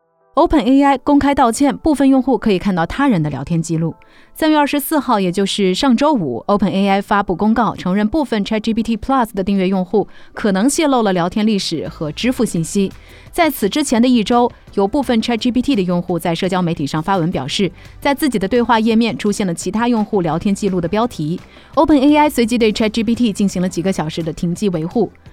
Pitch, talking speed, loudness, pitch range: 210 Hz, 380 characters per minute, -16 LUFS, 185-250 Hz